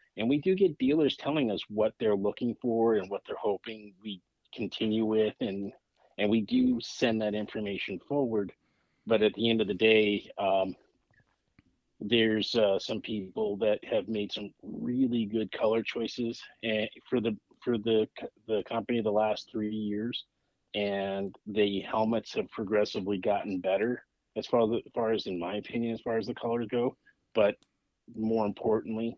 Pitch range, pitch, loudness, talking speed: 105-115 Hz, 110 Hz, -30 LUFS, 160 wpm